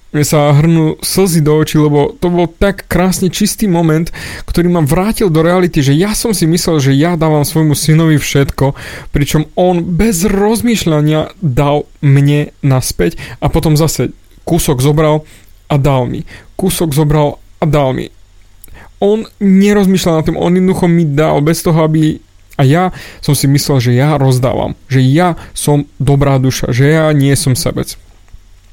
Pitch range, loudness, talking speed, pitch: 140-175 Hz, -11 LUFS, 160 wpm, 155 Hz